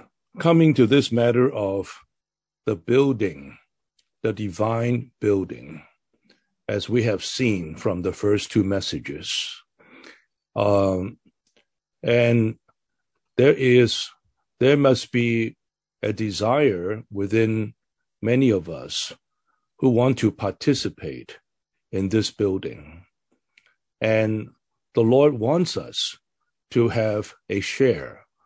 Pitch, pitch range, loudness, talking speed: 110 Hz, 100-125 Hz, -22 LUFS, 100 wpm